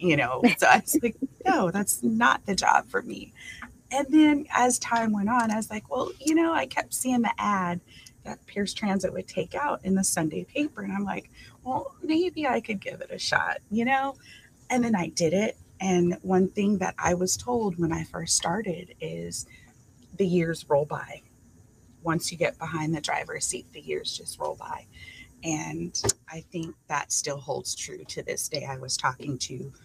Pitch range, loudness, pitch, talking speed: 160-245 Hz, -27 LUFS, 195 Hz, 200 wpm